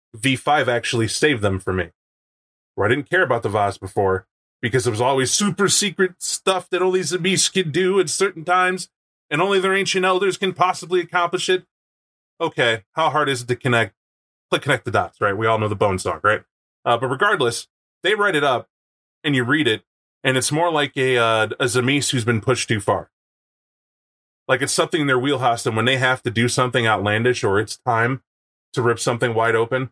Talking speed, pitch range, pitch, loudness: 215 wpm, 115-180 Hz, 130 Hz, -19 LUFS